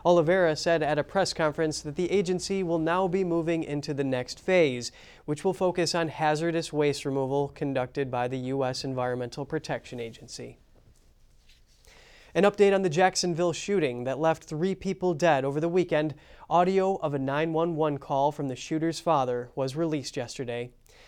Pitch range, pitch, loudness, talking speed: 140-175 Hz, 155 Hz, -27 LUFS, 160 wpm